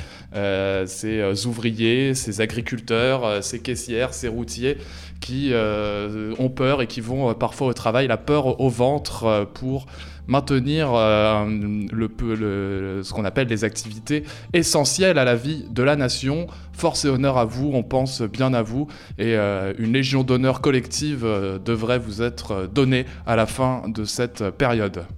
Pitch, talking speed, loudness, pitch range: 115 Hz, 170 wpm, -22 LUFS, 105-130 Hz